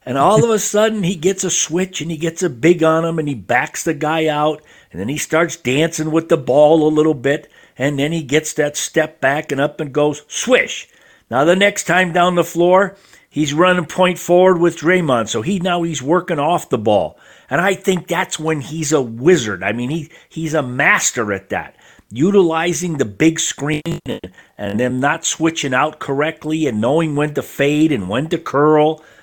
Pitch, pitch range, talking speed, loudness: 160 Hz, 150-175 Hz, 210 wpm, -16 LUFS